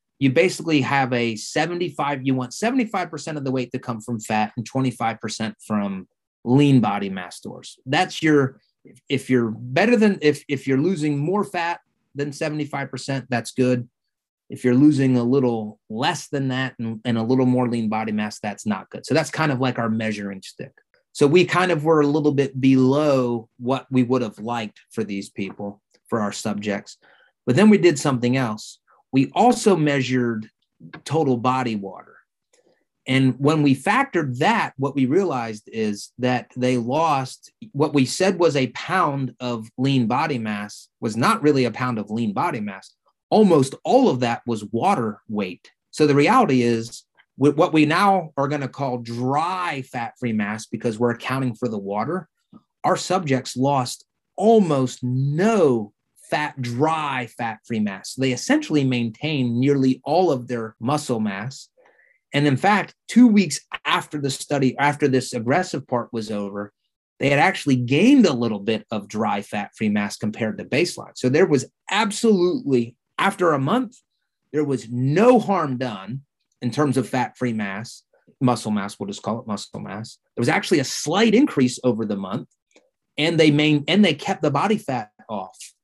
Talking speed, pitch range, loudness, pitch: 175 wpm, 115-150 Hz, -21 LUFS, 130 Hz